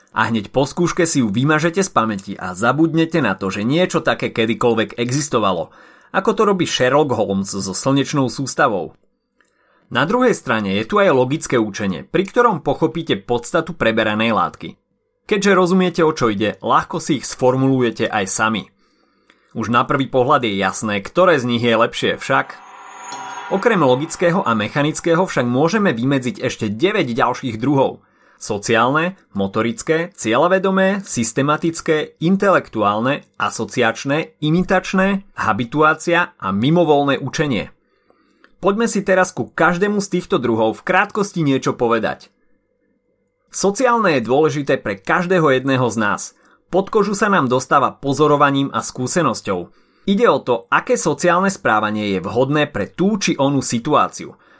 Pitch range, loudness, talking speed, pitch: 120-180 Hz, -17 LUFS, 140 wpm, 145 Hz